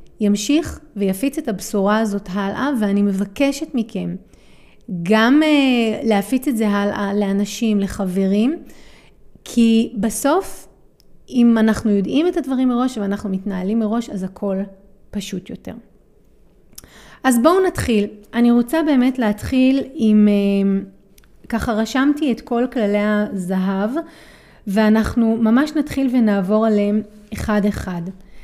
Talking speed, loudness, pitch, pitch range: 110 wpm, -18 LUFS, 220 Hz, 200-255 Hz